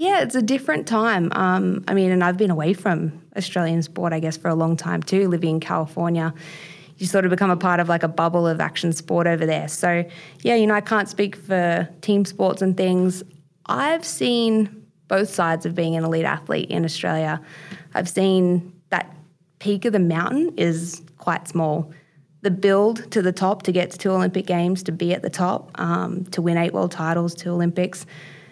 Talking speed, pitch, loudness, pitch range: 205 wpm, 175 Hz, -21 LUFS, 165-195 Hz